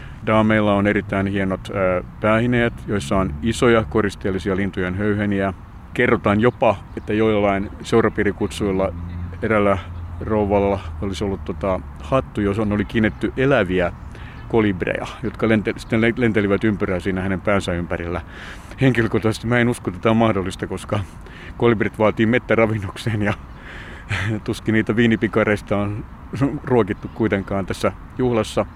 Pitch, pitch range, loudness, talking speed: 105 Hz, 95-110 Hz, -20 LUFS, 125 wpm